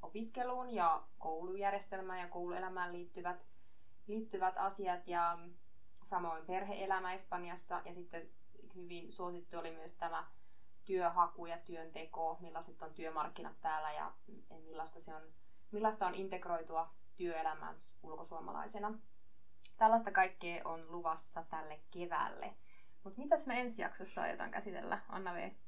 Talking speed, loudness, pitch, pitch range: 115 wpm, -38 LUFS, 175 Hz, 165-190 Hz